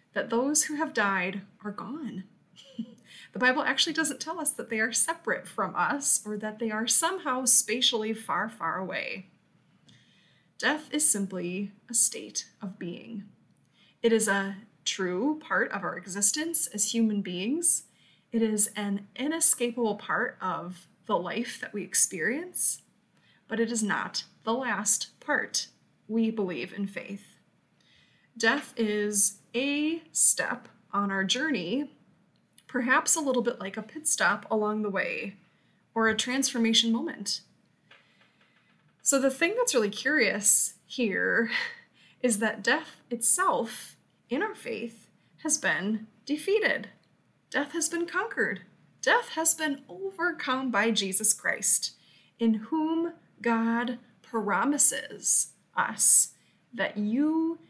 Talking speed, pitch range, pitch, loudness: 130 wpm, 210-295 Hz, 230 Hz, -27 LUFS